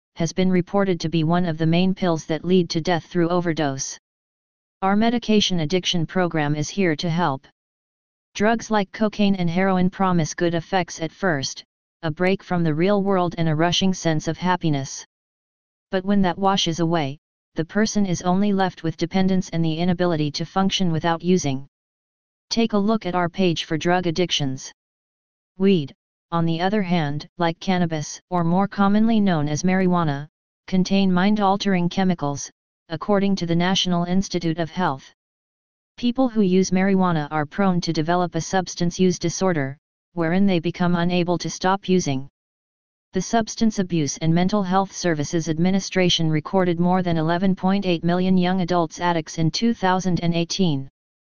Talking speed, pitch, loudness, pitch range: 160 wpm, 180 Hz, -21 LUFS, 165-190 Hz